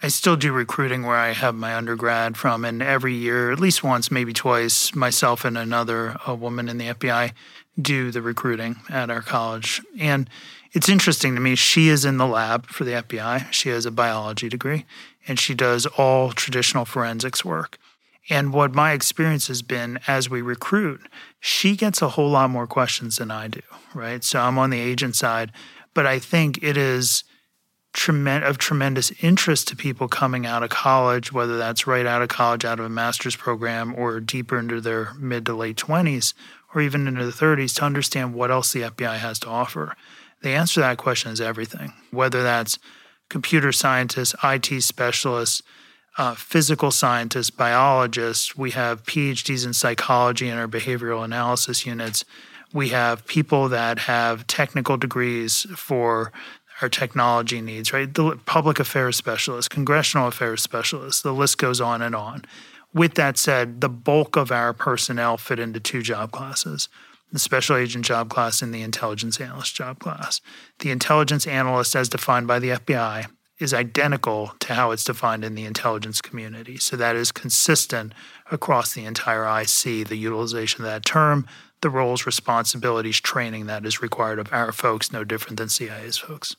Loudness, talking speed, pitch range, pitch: -21 LUFS, 175 wpm, 115-140 Hz, 125 Hz